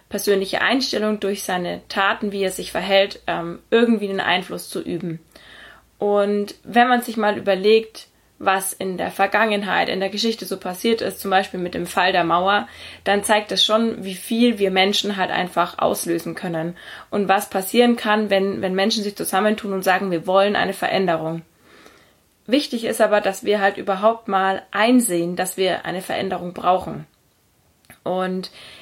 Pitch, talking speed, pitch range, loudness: 195 Hz, 165 wpm, 185-210 Hz, -20 LUFS